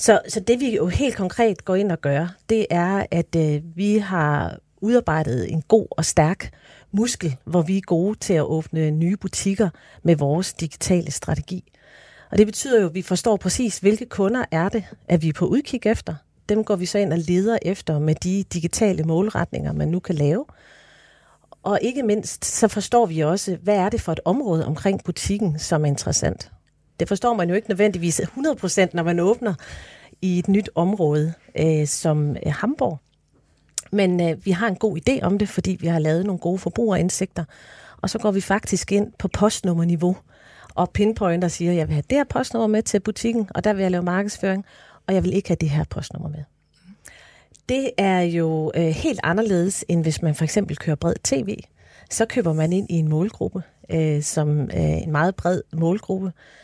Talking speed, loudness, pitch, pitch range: 195 wpm, -22 LUFS, 185 Hz, 160-210 Hz